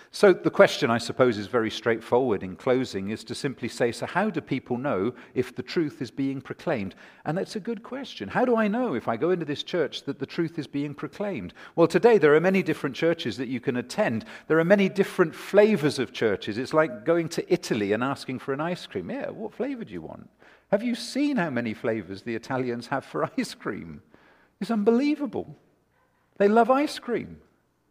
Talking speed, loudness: 215 wpm, -26 LUFS